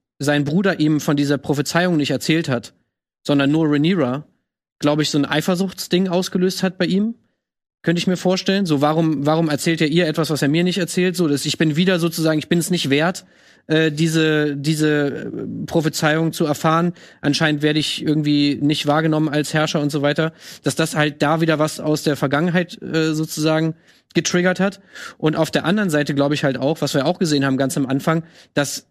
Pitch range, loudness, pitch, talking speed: 150-170 Hz, -19 LUFS, 155 Hz, 200 wpm